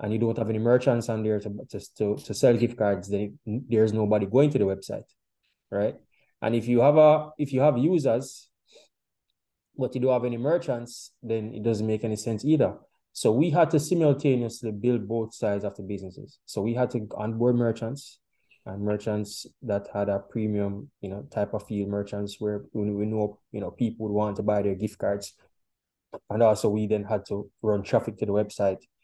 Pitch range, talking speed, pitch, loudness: 105-120 Hz, 200 wpm, 110 Hz, -26 LUFS